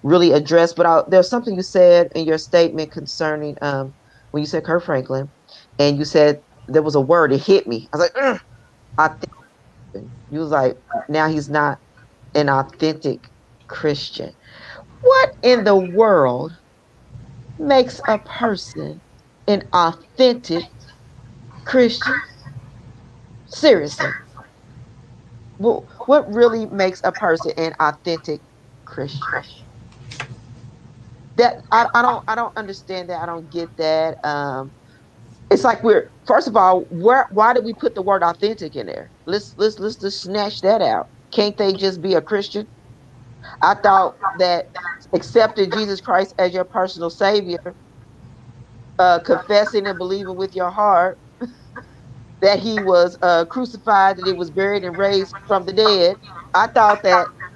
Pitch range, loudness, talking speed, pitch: 135-200 Hz, -18 LUFS, 145 wpm, 170 Hz